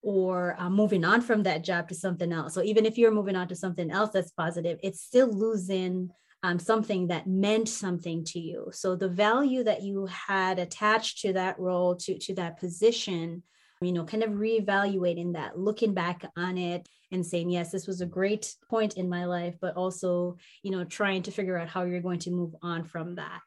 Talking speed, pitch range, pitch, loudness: 210 wpm, 175-205 Hz, 185 Hz, -29 LUFS